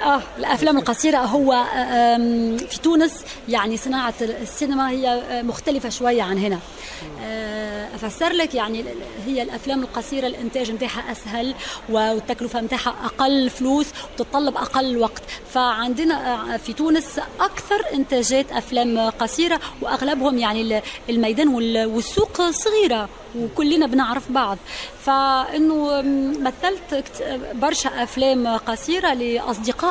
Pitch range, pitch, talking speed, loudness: 235-280 Hz, 255 Hz, 100 wpm, -21 LUFS